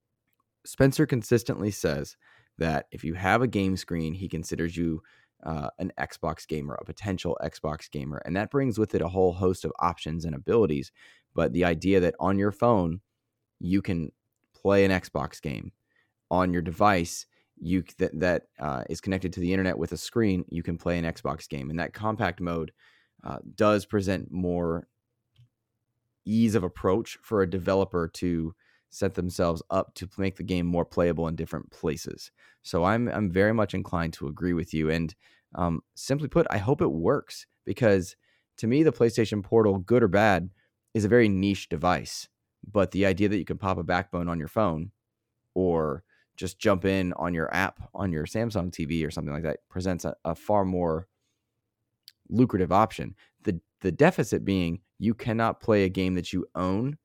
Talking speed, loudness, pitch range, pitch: 180 wpm, -27 LUFS, 85-105 Hz, 95 Hz